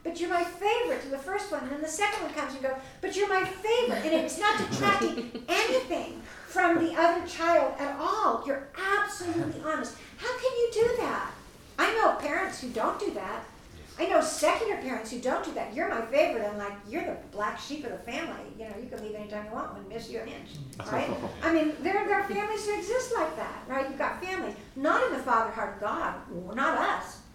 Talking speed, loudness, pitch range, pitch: 225 wpm, -29 LUFS, 265-395 Hz, 330 Hz